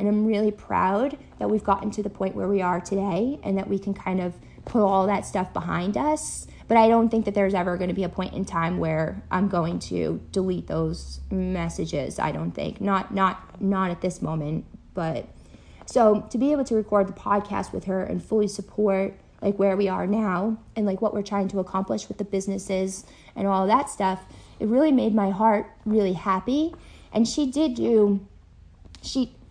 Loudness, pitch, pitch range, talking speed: -25 LUFS, 195 Hz, 185-215 Hz, 205 wpm